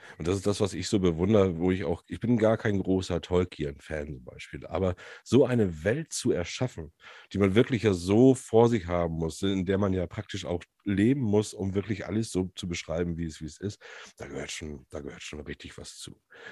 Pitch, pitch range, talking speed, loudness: 95 Hz, 85-105 Hz, 225 wpm, -28 LUFS